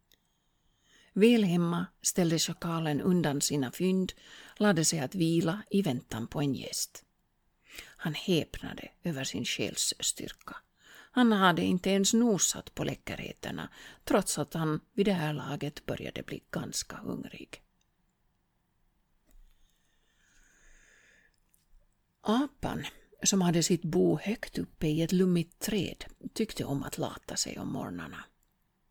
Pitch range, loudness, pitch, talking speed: 155-205 Hz, -30 LUFS, 175 Hz, 115 wpm